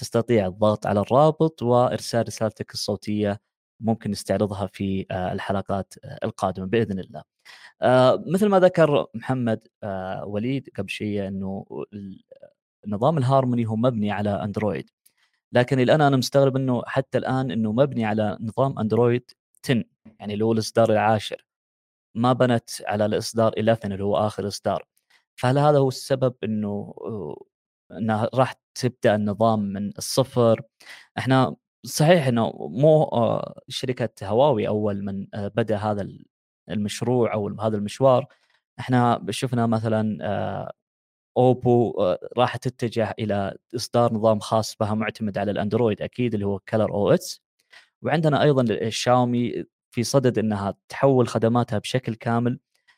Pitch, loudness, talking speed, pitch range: 115 Hz, -23 LUFS, 125 wpm, 105-125 Hz